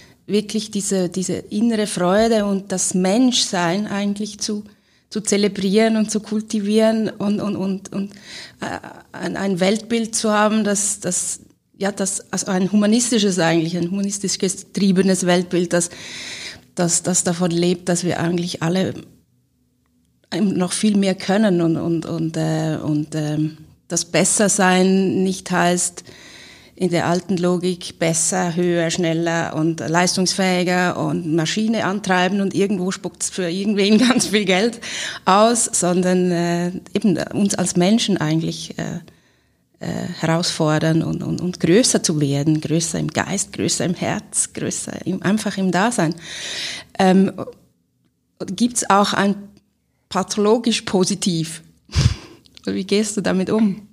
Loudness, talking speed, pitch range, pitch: -19 LUFS, 130 wpm, 170-205 Hz, 185 Hz